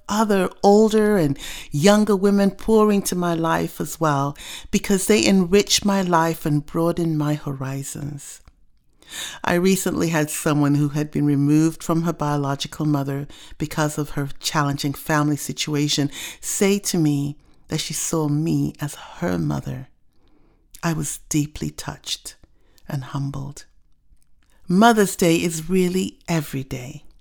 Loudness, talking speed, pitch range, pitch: -21 LUFS, 130 wpm, 145-180 Hz, 155 Hz